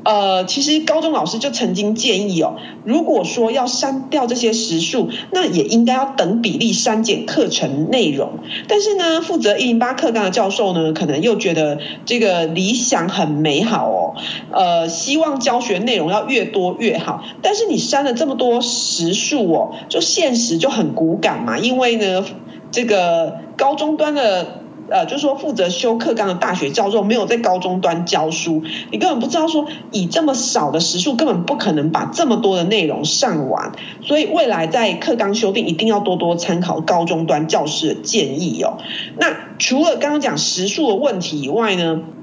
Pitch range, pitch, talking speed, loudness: 180-270 Hz, 225 Hz, 275 characters per minute, -17 LUFS